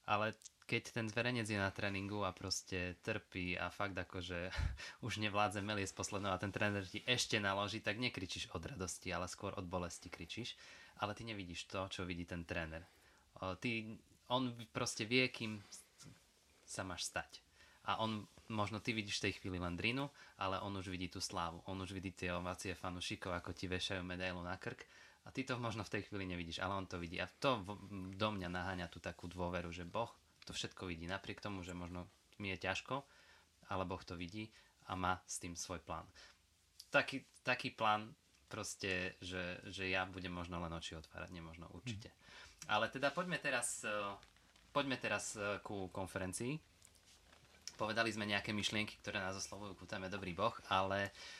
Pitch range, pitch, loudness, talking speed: 90-105 Hz, 95 Hz, -42 LUFS, 175 wpm